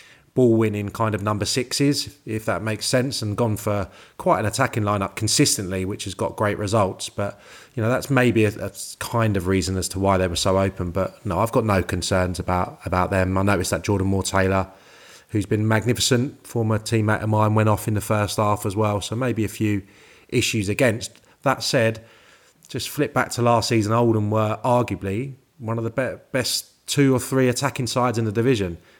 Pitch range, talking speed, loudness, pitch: 100-120 Hz, 205 wpm, -22 LUFS, 110 Hz